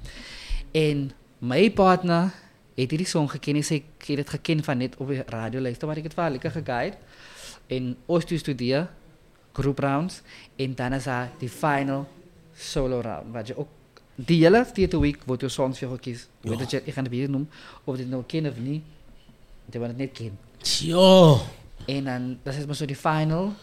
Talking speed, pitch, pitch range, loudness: 185 wpm, 140 Hz, 125-155 Hz, -25 LUFS